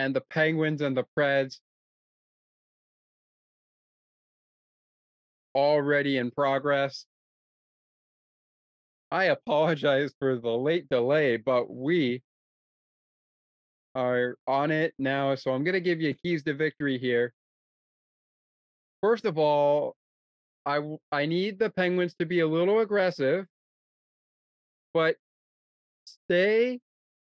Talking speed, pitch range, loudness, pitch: 100 wpm, 130-165 Hz, -27 LUFS, 145 Hz